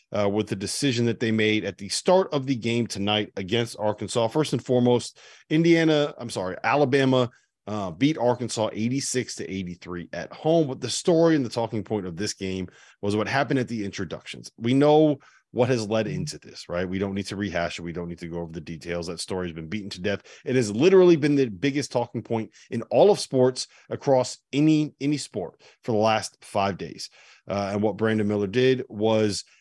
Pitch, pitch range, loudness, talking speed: 115 Hz, 100-135 Hz, -24 LUFS, 210 wpm